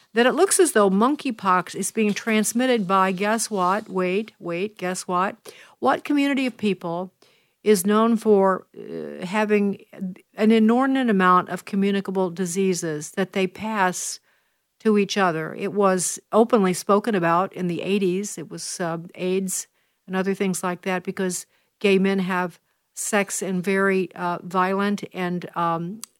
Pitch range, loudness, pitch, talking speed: 180-210 Hz, -22 LUFS, 195 Hz, 150 wpm